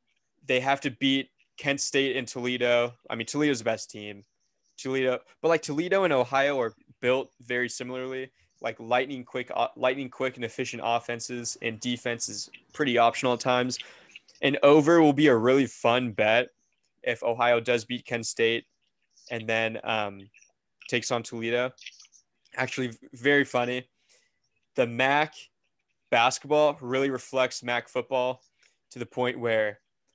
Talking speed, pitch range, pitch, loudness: 145 wpm, 120-135 Hz, 125 Hz, -26 LUFS